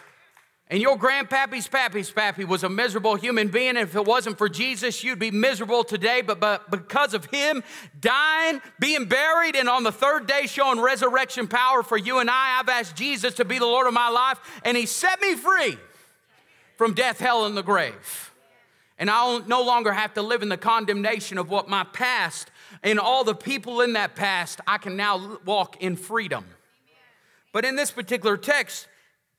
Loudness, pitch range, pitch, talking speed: -23 LUFS, 210-260 Hz, 240 Hz, 190 wpm